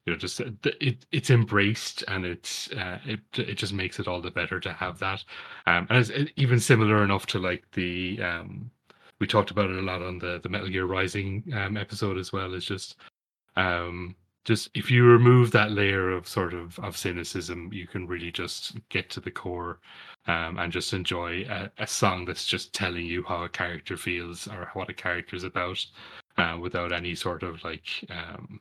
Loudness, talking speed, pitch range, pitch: -27 LUFS, 200 wpm, 90-105 Hz, 95 Hz